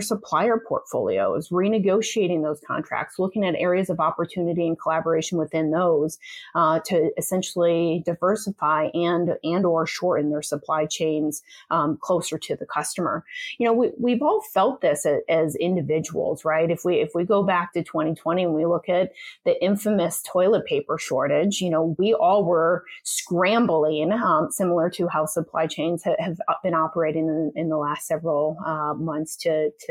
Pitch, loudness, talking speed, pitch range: 170 Hz, -23 LUFS, 165 wpm, 160-185 Hz